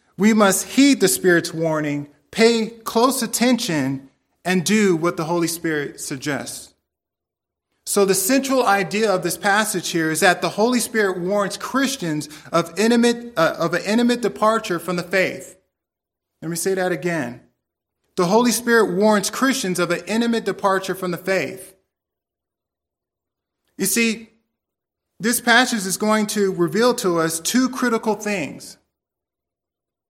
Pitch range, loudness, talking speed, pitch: 165-225 Hz, -19 LUFS, 140 wpm, 190 Hz